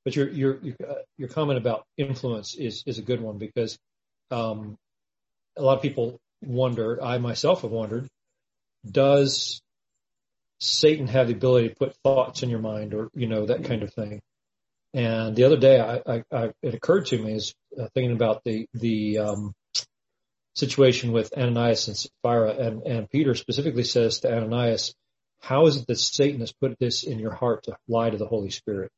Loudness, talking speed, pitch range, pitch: -24 LUFS, 180 wpm, 115-135 Hz, 120 Hz